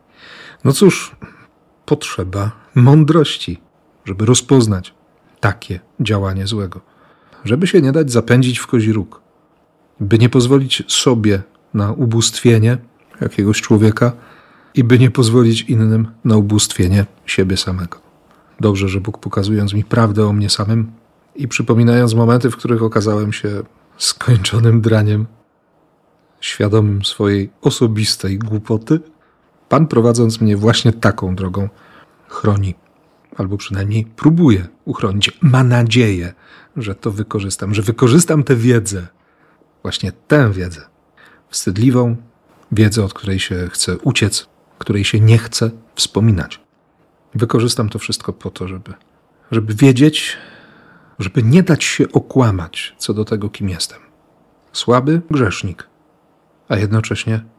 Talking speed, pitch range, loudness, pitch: 120 wpm, 100-125 Hz, -15 LUFS, 110 Hz